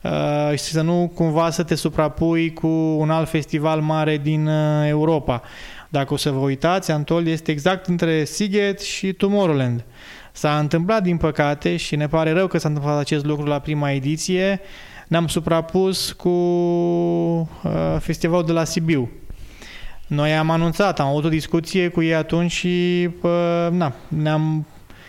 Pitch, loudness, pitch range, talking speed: 160 Hz, -20 LUFS, 150-175 Hz, 155 wpm